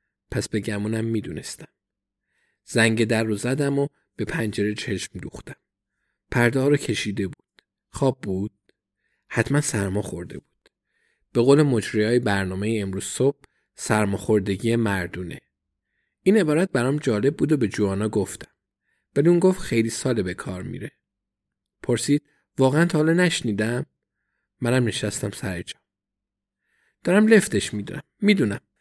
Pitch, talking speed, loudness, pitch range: 115 Hz, 135 wpm, -23 LUFS, 100-135 Hz